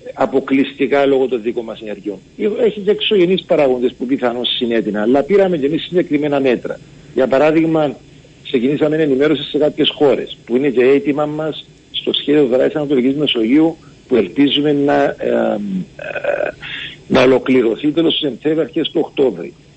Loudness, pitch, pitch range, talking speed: -15 LUFS, 145 Hz, 130-155 Hz, 150 wpm